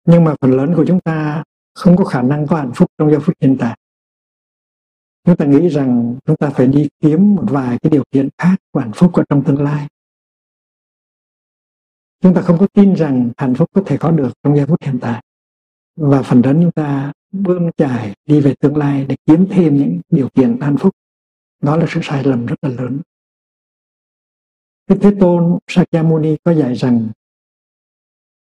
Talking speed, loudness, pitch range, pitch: 195 wpm, -14 LUFS, 135-170 Hz, 150 Hz